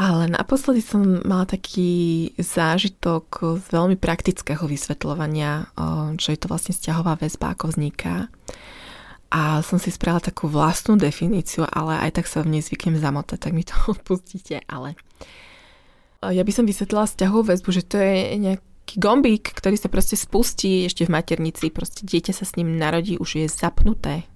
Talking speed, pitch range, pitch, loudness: 160 wpm, 160-190 Hz, 170 Hz, -22 LUFS